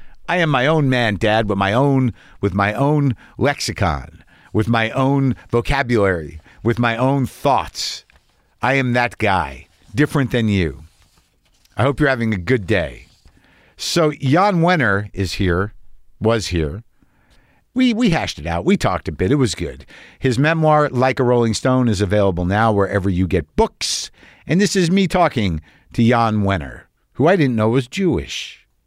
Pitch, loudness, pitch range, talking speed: 115 Hz, -18 LUFS, 100-135 Hz, 170 wpm